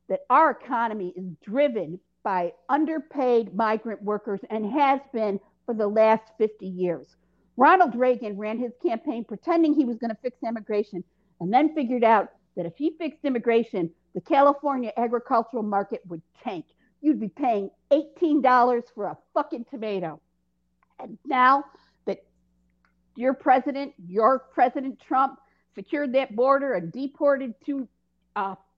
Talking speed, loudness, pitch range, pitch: 140 wpm, -25 LUFS, 200-275 Hz, 235 Hz